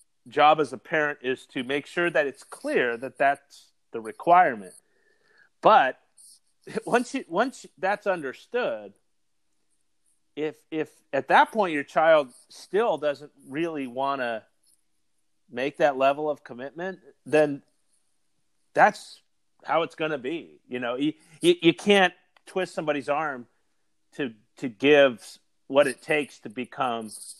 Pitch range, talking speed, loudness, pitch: 135-190 Hz, 135 wpm, -25 LUFS, 150 Hz